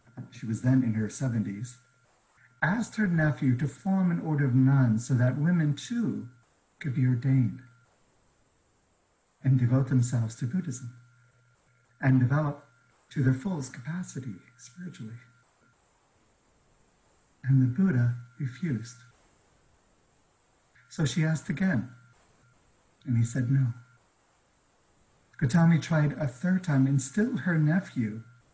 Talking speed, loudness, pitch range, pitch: 115 wpm, -27 LUFS, 125-155 Hz, 130 Hz